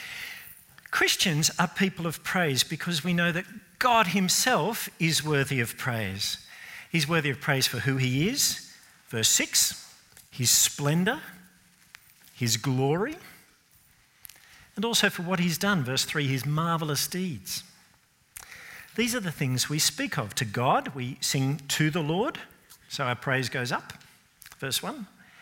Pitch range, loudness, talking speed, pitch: 135-190 Hz, -26 LUFS, 145 wpm, 160 Hz